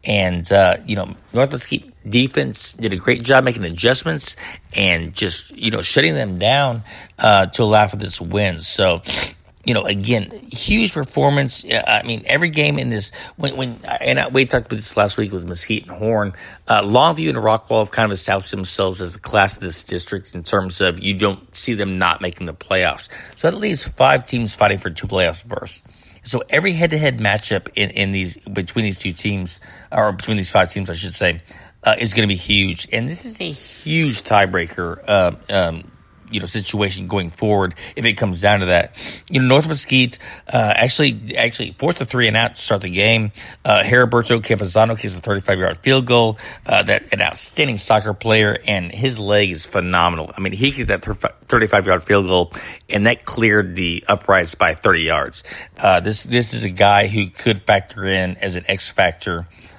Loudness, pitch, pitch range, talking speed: -17 LUFS, 105 Hz, 95-120 Hz, 200 wpm